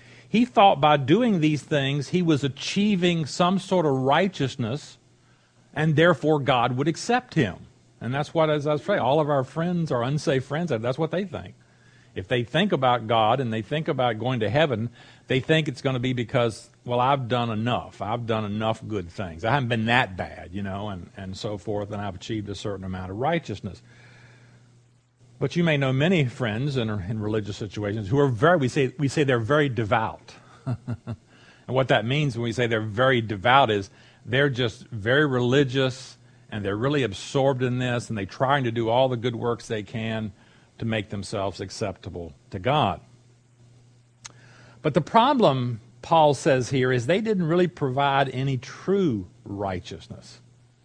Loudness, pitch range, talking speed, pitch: -24 LUFS, 115-145 Hz, 185 wpm, 125 Hz